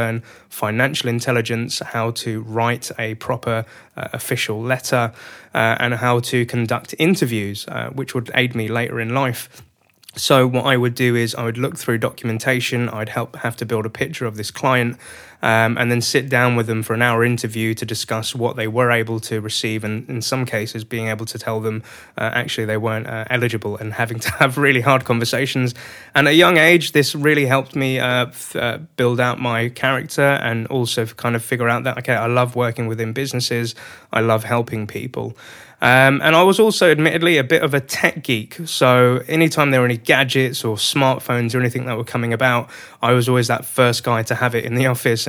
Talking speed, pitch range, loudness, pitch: 210 wpm, 115-130 Hz, -18 LUFS, 120 Hz